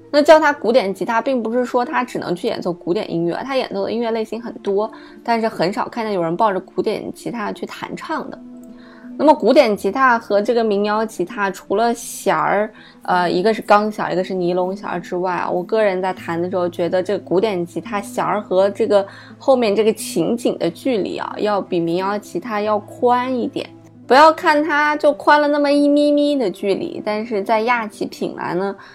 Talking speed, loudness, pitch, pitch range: 305 characters per minute, -18 LUFS, 220 Hz, 190-250 Hz